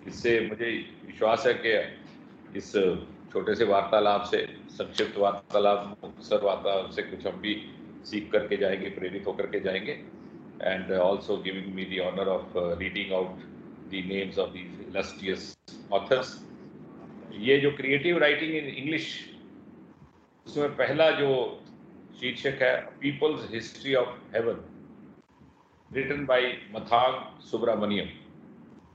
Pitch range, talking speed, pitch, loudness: 100-140 Hz, 120 wpm, 110 Hz, -28 LUFS